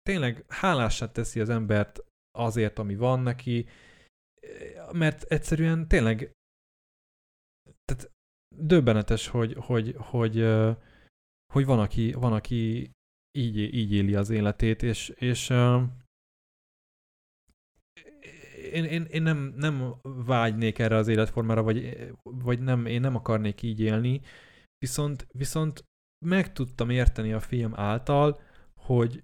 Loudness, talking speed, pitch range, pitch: -27 LUFS, 115 wpm, 110-135 Hz, 120 Hz